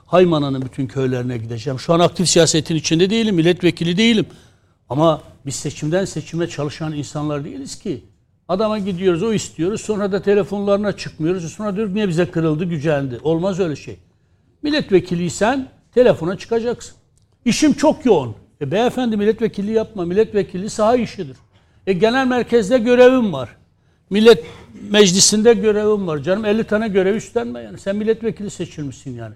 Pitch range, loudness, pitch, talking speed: 150-215 Hz, -18 LUFS, 185 Hz, 140 wpm